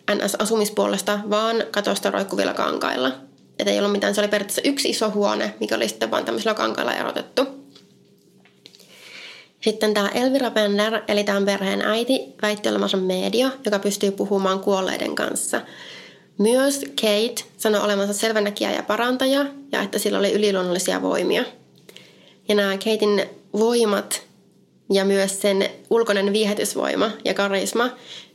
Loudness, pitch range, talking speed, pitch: -21 LUFS, 200-225 Hz, 135 wpm, 210 Hz